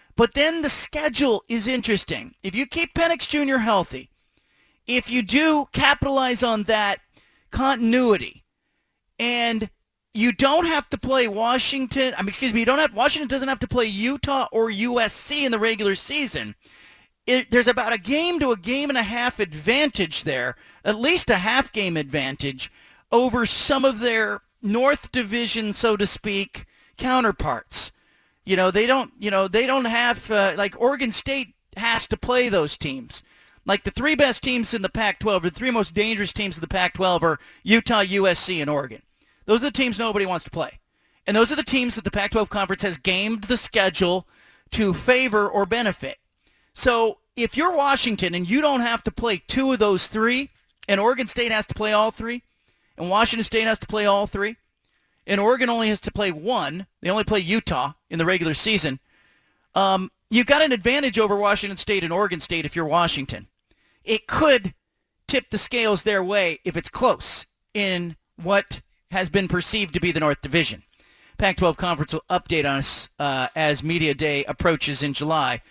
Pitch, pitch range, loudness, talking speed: 215 Hz, 185-250 Hz, -22 LUFS, 180 wpm